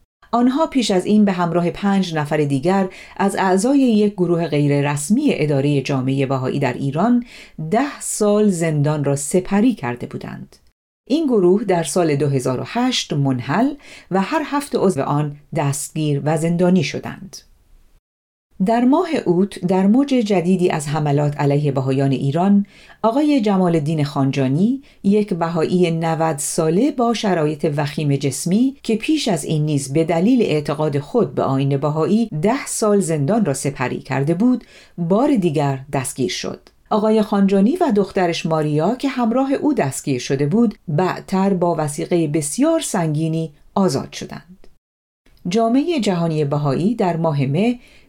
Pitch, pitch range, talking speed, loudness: 175 Hz, 145-215 Hz, 140 wpm, -18 LUFS